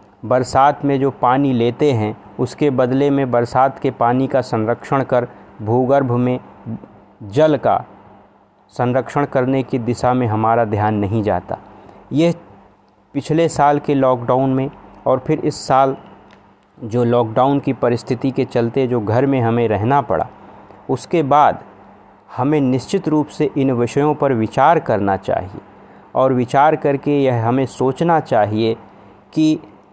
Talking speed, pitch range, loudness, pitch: 140 wpm, 120-140 Hz, -17 LUFS, 130 Hz